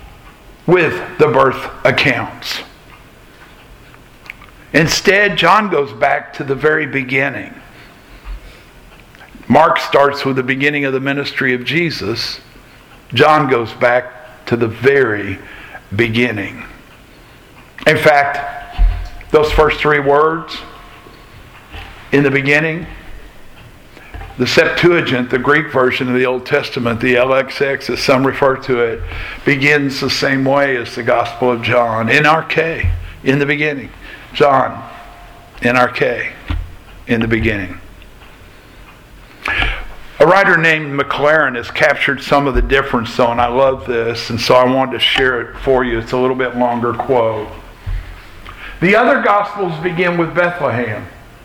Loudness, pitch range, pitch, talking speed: -14 LUFS, 115-145 Hz, 130 Hz, 130 wpm